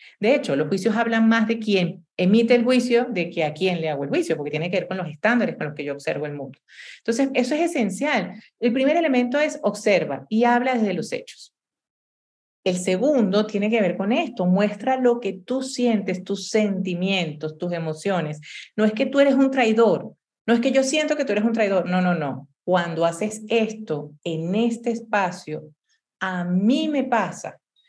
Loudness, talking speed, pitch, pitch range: -22 LUFS, 200 wpm, 210 Hz, 180-240 Hz